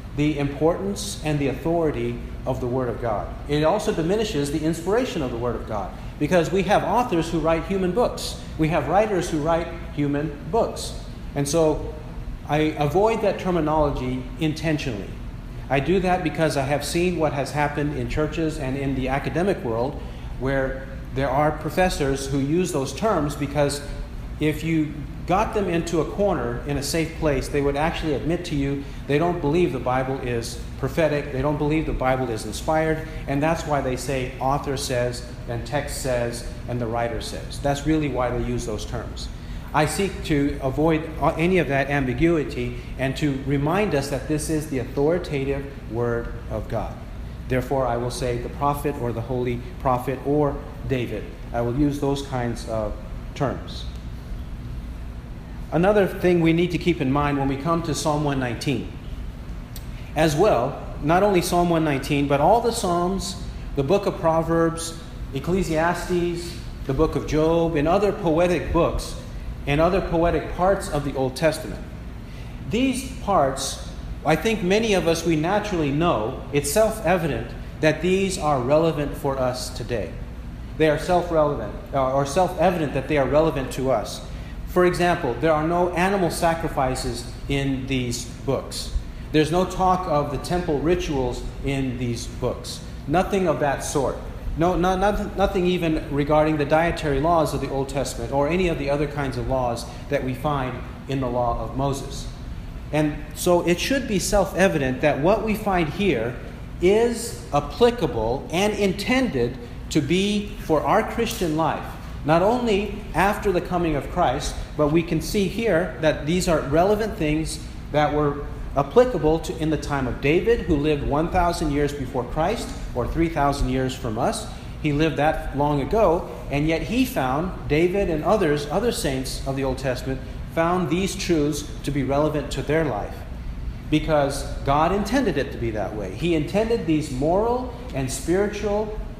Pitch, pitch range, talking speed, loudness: 150 Hz, 130-170 Hz, 165 wpm, -23 LUFS